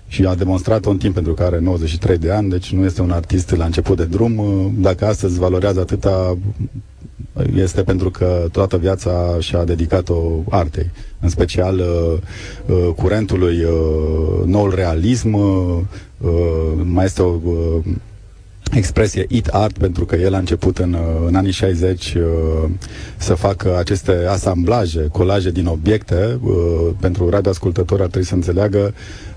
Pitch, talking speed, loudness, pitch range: 95 Hz, 145 wpm, -17 LUFS, 85-100 Hz